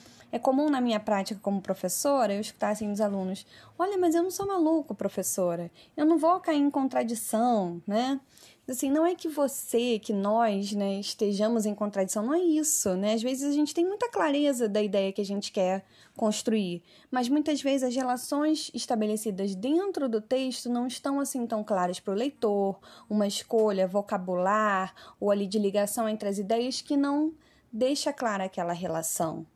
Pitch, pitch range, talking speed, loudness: 225 Hz, 200-280 Hz, 180 wpm, -28 LUFS